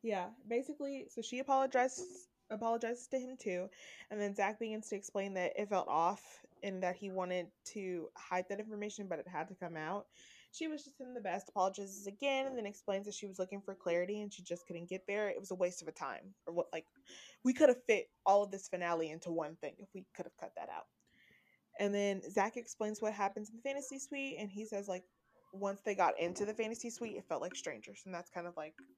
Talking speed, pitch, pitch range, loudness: 235 wpm, 200 Hz, 185-230 Hz, -39 LUFS